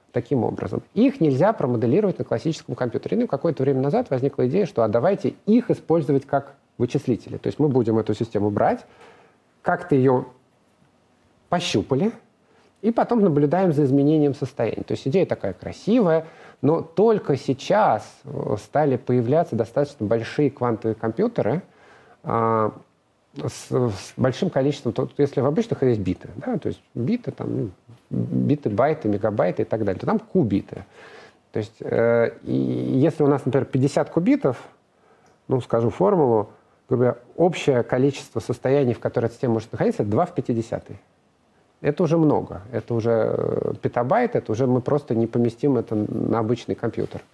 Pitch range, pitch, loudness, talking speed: 115-150 Hz, 135 Hz, -22 LUFS, 150 wpm